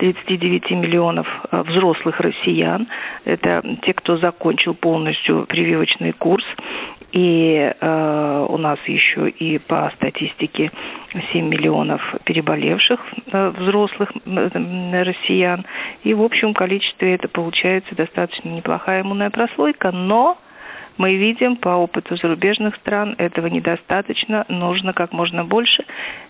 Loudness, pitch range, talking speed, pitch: -18 LUFS, 170-205 Hz, 110 wpm, 180 Hz